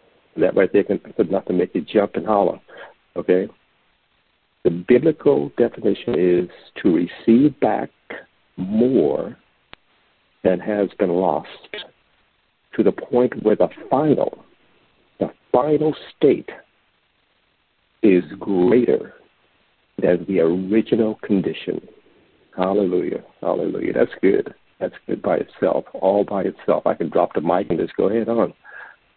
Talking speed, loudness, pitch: 125 wpm, -20 LUFS, 125 Hz